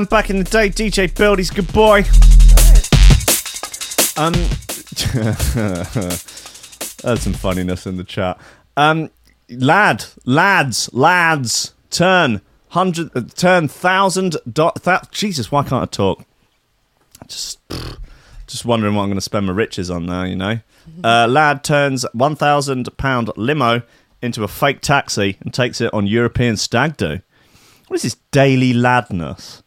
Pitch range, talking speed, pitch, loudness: 105-160 Hz, 135 wpm, 125 Hz, -16 LUFS